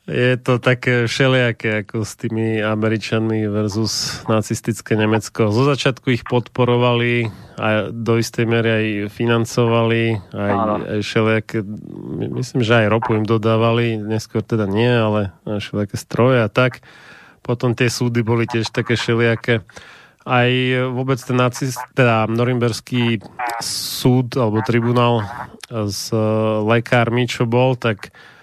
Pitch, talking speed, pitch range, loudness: 115 Hz, 120 wpm, 110-125 Hz, -18 LUFS